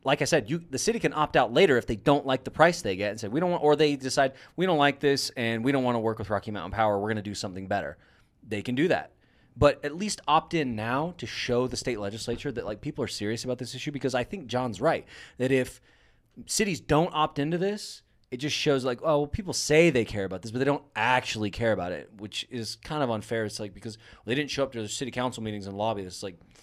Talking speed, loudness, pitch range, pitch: 270 wpm, -27 LUFS, 110-145 Hz, 125 Hz